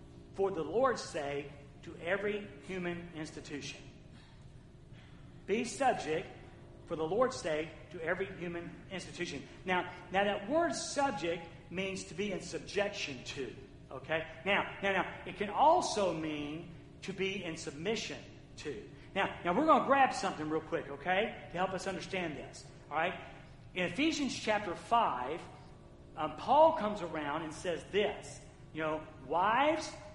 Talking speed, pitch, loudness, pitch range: 145 wpm, 175 Hz, -35 LUFS, 155-195 Hz